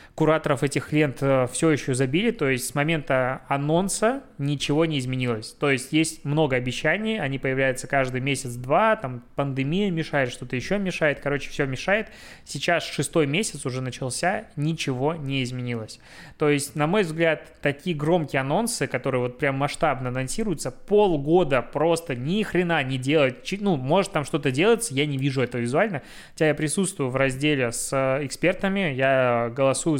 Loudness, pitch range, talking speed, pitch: -24 LUFS, 130-165 Hz, 155 wpm, 145 Hz